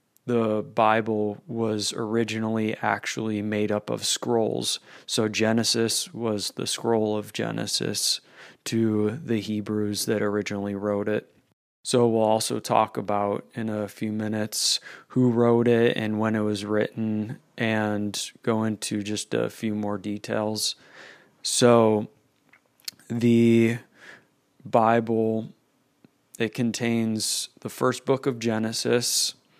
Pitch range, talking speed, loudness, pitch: 105-115 Hz, 120 wpm, -25 LUFS, 110 Hz